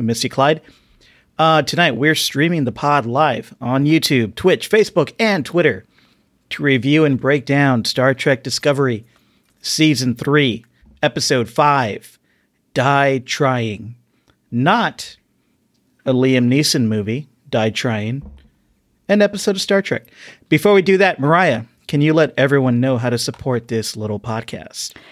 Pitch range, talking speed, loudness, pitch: 120-155 Hz, 135 wpm, -16 LUFS, 140 Hz